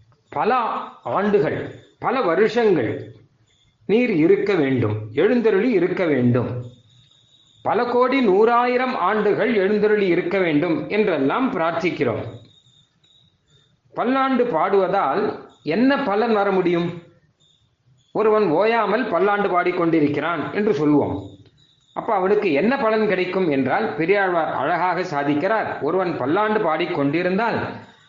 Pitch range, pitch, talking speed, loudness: 140-215 Hz, 175 Hz, 90 wpm, -20 LUFS